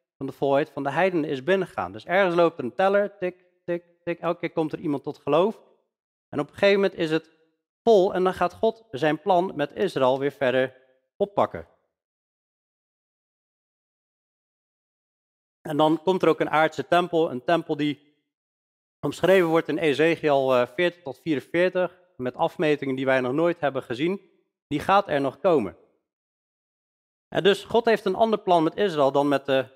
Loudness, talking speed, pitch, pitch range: -24 LUFS, 170 wpm, 160 Hz, 140-180 Hz